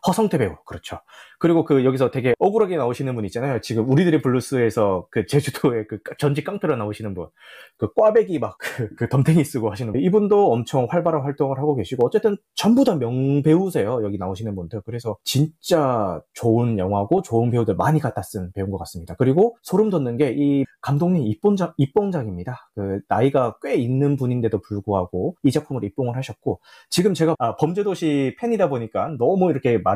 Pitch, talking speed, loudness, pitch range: 135 Hz, 400 characters per minute, -21 LUFS, 115-160 Hz